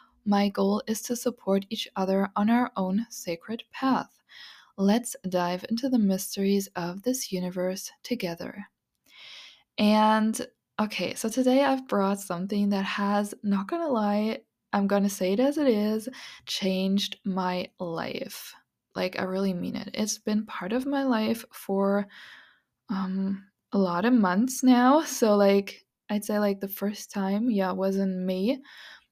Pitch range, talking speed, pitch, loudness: 195-230 Hz, 150 wpm, 205 Hz, -27 LUFS